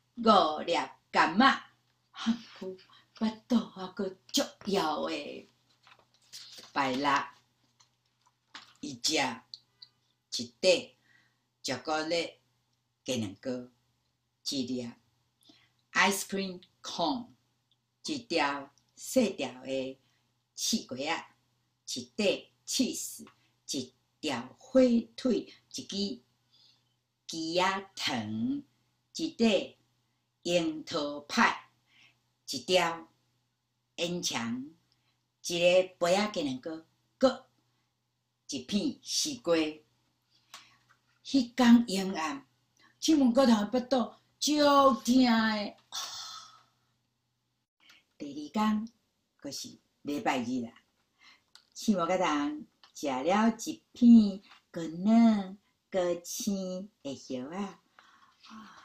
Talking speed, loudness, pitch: 125 characters per minute, -30 LUFS, 185 Hz